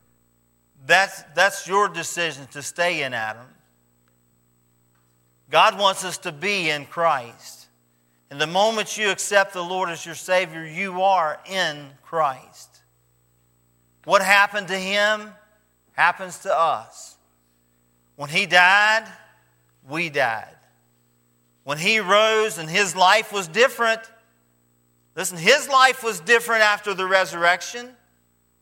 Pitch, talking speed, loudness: 170 Hz, 120 wpm, -20 LUFS